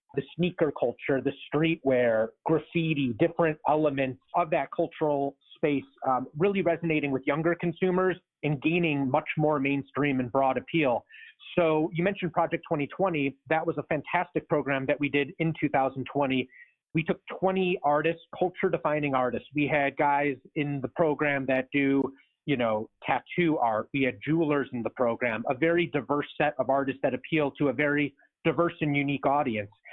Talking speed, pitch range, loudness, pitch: 160 wpm, 135-165 Hz, -28 LUFS, 150 Hz